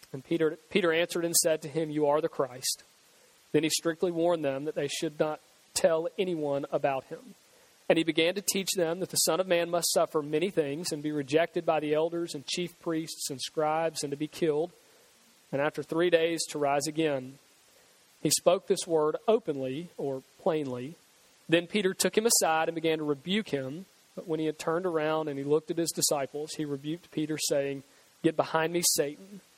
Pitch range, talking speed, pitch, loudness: 150-170 Hz, 200 wpm, 160 Hz, -29 LUFS